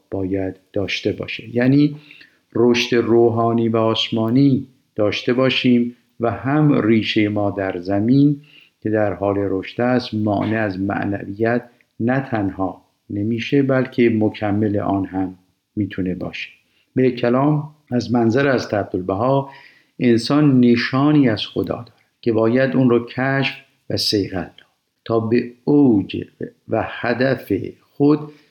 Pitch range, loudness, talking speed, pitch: 105-130 Hz, -19 LUFS, 125 wpm, 115 Hz